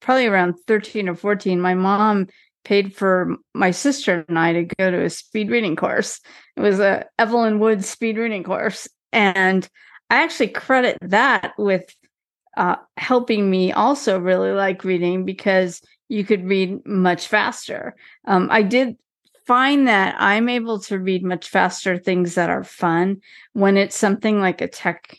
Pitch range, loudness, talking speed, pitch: 185-225 Hz, -19 LUFS, 160 wpm, 200 Hz